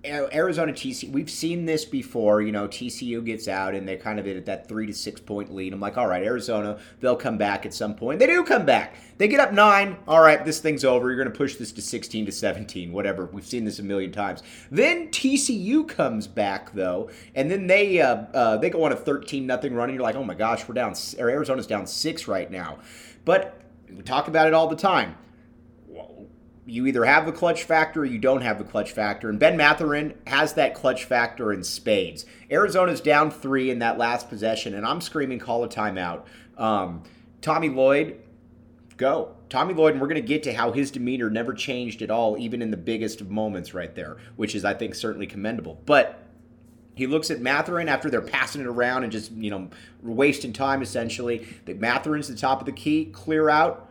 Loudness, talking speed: -24 LUFS, 215 wpm